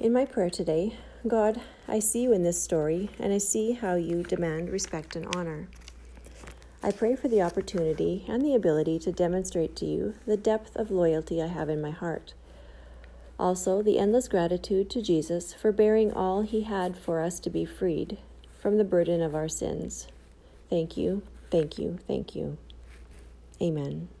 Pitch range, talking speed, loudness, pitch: 155-205 Hz, 175 wpm, -28 LUFS, 175 Hz